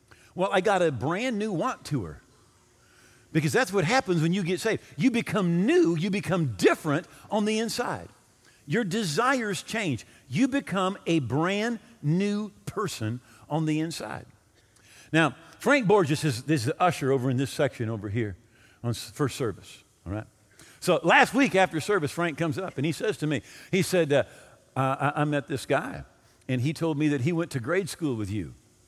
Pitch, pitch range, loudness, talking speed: 155 Hz, 125-190 Hz, -27 LUFS, 185 wpm